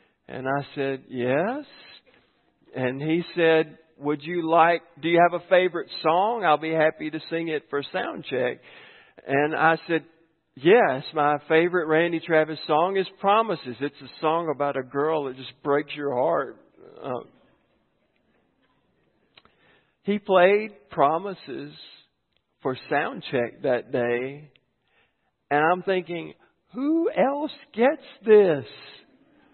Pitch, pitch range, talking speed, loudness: 160 Hz, 145-190 Hz, 130 wpm, -24 LUFS